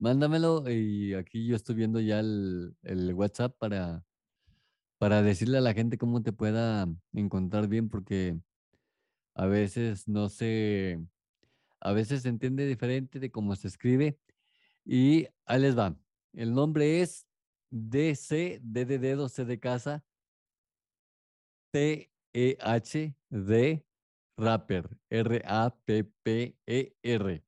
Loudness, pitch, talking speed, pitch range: -30 LUFS, 115 Hz, 105 wpm, 105-130 Hz